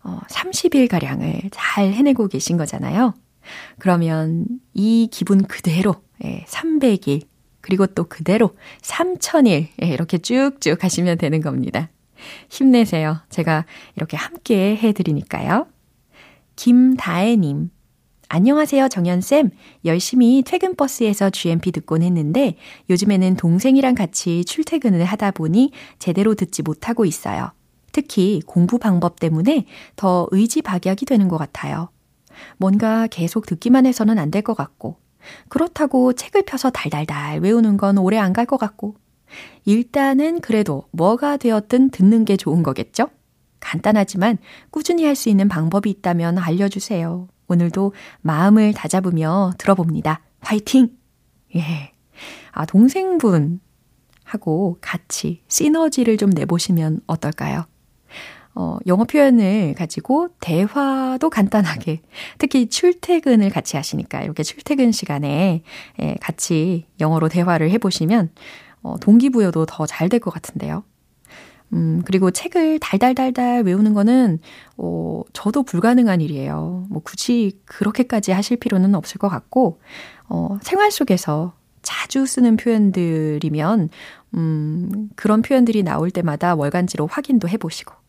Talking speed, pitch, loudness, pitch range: 280 characters per minute, 195 Hz, -18 LUFS, 170-240 Hz